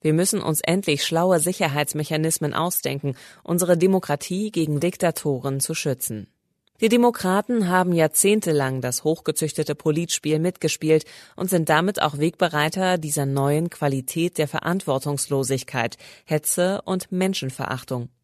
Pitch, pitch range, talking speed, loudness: 155 Hz, 145-180 Hz, 110 wpm, -22 LUFS